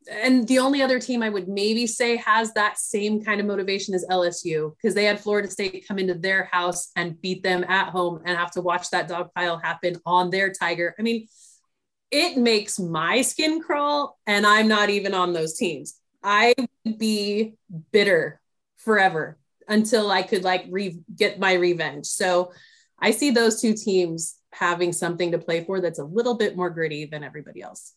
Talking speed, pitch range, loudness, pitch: 190 wpm, 175-220 Hz, -23 LUFS, 195 Hz